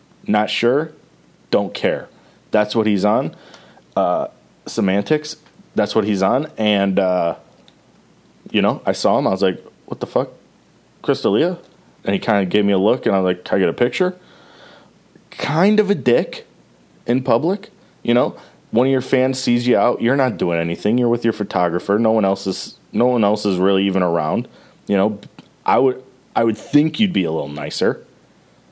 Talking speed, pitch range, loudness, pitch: 190 wpm, 100-130 Hz, -18 LUFS, 115 Hz